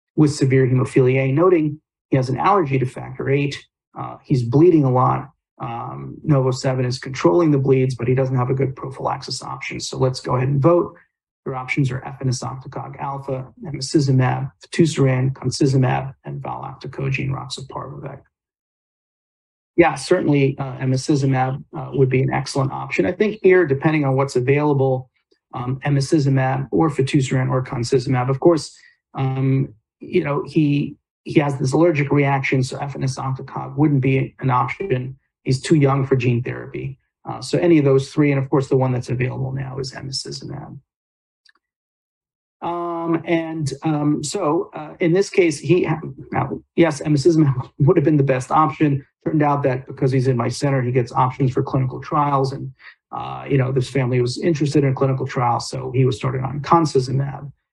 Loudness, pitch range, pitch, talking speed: -19 LUFS, 130-150 Hz, 135 Hz, 165 wpm